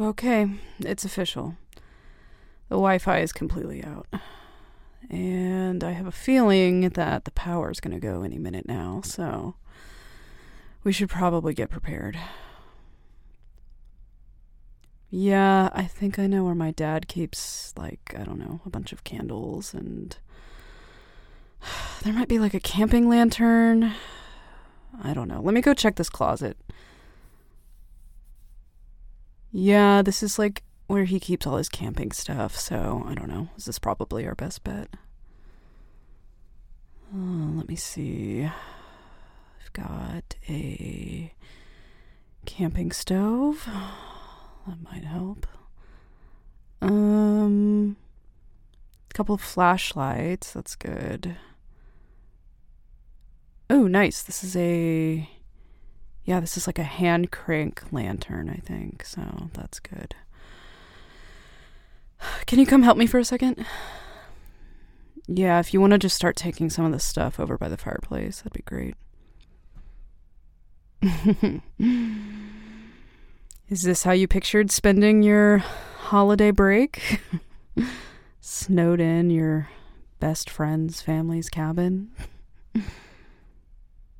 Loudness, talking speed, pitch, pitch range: -24 LUFS, 115 wpm, 180 Hz, 155-205 Hz